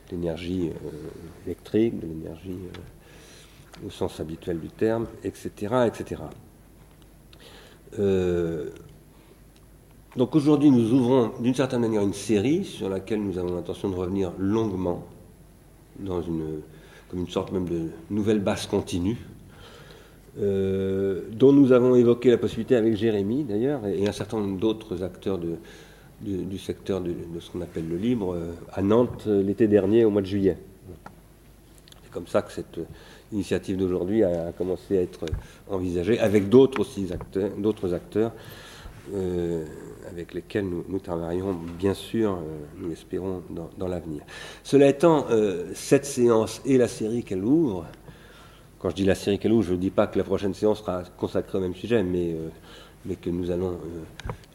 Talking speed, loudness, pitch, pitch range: 165 wpm, -25 LUFS, 95 Hz, 90-110 Hz